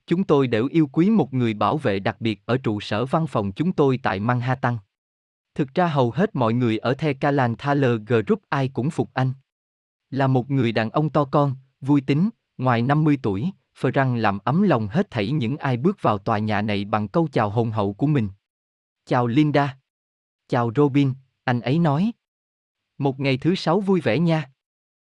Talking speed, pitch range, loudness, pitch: 195 wpm, 110-150 Hz, -22 LUFS, 130 Hz